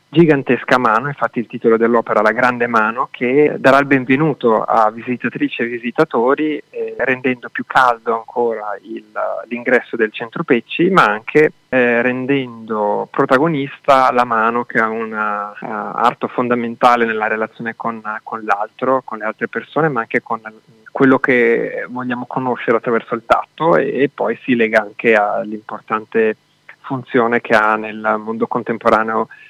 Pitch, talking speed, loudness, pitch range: 120 Hz, 145 wpm, -16 LUFS, 110-130 Hz